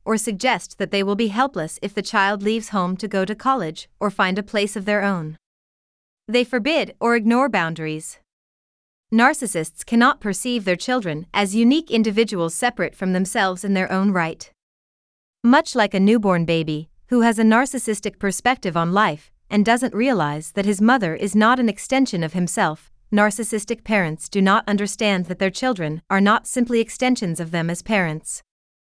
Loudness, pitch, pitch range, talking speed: -20 LUFS, 210 Hz, 185-230 Hz, 170 wpm